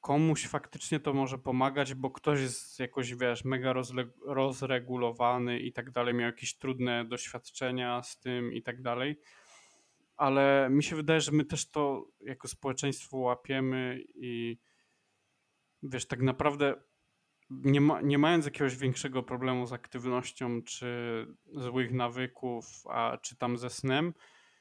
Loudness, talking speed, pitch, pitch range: -32 LUFS, 135 wpm, 130 Hz, 125-140 Hz